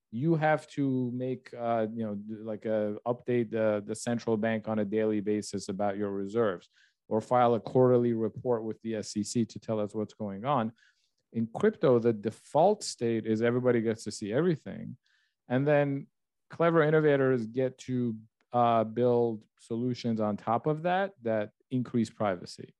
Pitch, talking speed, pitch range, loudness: 115 Hz, 165 wpm, 110-125 Hz, -30 LUFS